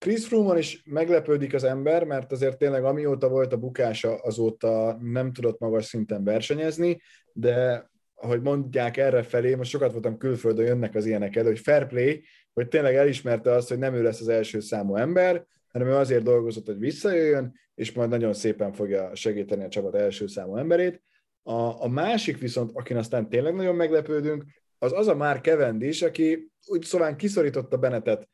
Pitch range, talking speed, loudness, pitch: 115-160 Hz, 175 wpm, -25 LUFS, 130 Hz